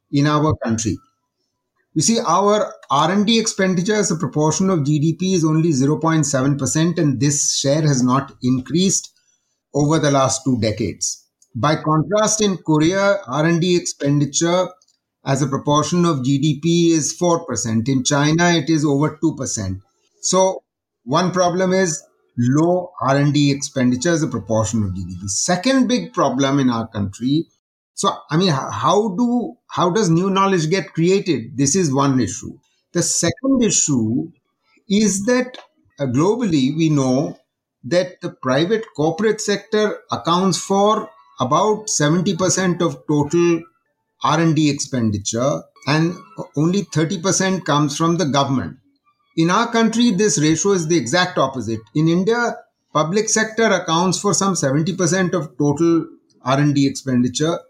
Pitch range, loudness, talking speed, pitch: 140-185 Hz, -18 LUFS, 140 wpm, 160 Hz